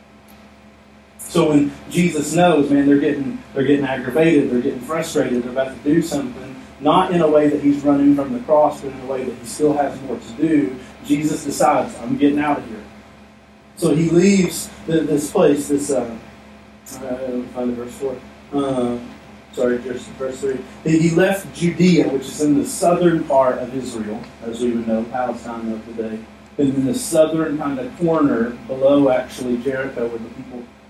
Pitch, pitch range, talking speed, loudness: 140 Hz, 125-155 Hz, 190 wpm, -19 LUFS